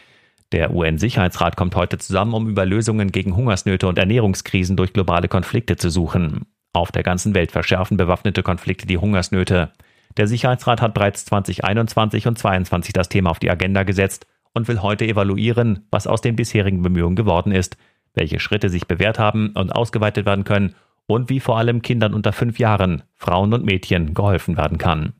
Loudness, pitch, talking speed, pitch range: -19 LUFS, 100 Hz, 175 wpm, 90-110 Hz